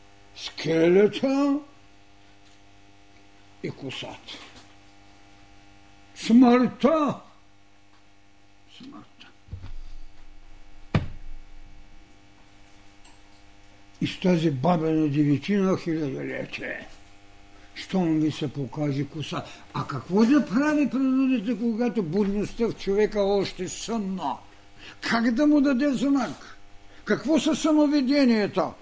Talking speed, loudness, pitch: 75 wpm, -24 LUFS, 135 Hz